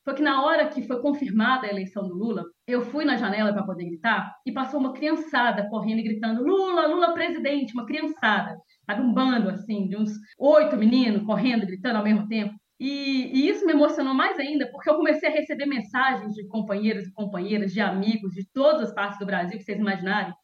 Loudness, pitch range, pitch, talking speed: -24 LUFS, 210-280 Hz, 230 Hz, 210 wpm